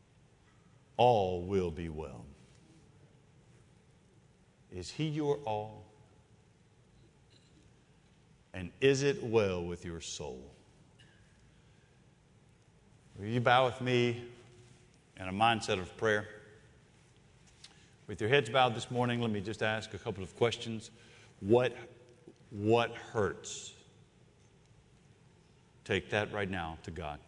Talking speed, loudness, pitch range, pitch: 105 wpm, -33 LUFS, 100-125 Hz, 110 Hz